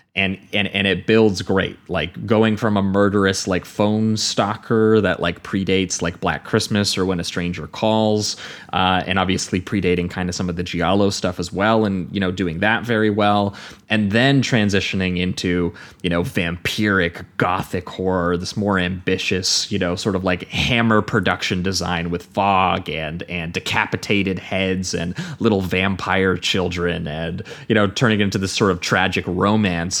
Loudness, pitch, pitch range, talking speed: -19 LUFS, 95 Hz, 90-105 Hz, 170 wpm